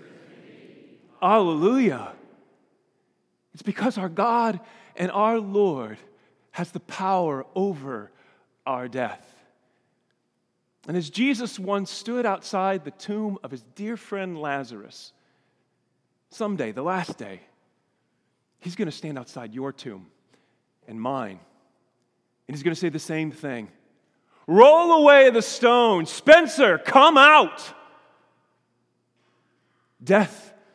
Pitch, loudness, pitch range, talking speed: 190 Hz, -20 LUFS, 145-225 Hz, 110 wpm